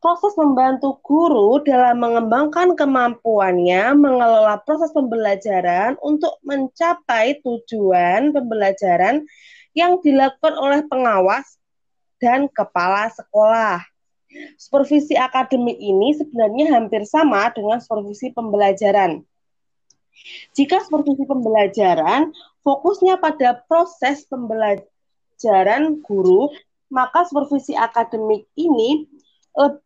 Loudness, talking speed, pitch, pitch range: -17 LUFS, 85 wpm, 260 Hz, 220-305 Hz